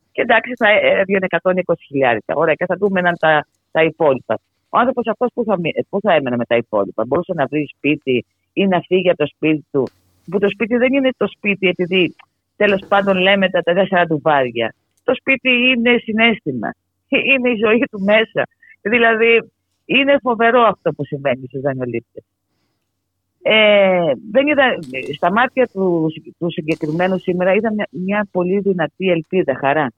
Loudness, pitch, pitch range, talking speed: -16 LUFS, 185 Hz, 150-225 Hz, 155 wpm